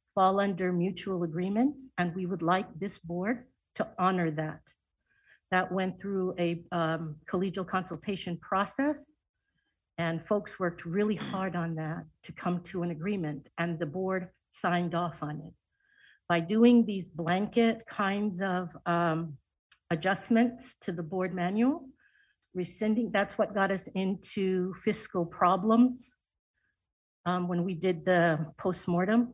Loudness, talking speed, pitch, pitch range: -30 LUFS, 135 wpm, 185 Hz, 175-210 Hz